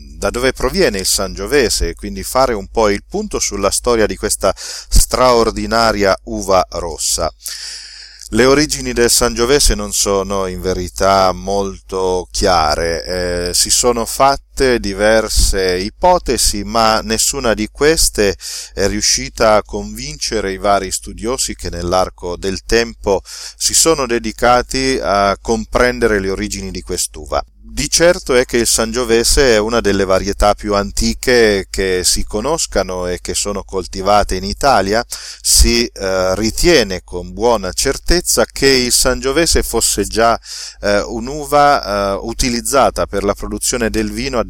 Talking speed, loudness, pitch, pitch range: 130 wpm, -14 LUFS, 105 Hz, 95-120 Hz